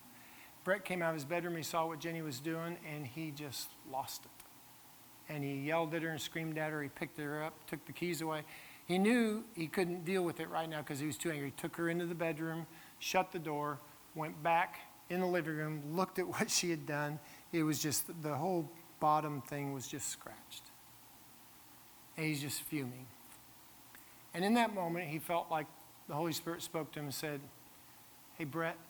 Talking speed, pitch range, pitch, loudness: 210 wpm, 150-170 Hz, 160 Hz, -38 LUFS